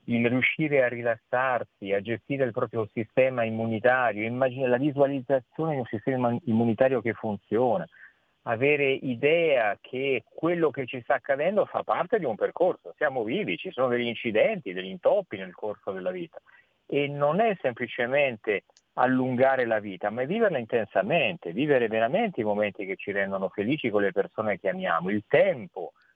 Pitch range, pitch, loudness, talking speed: 110-140 Hz, 125 Hz, -26 LUFS, 160 wpm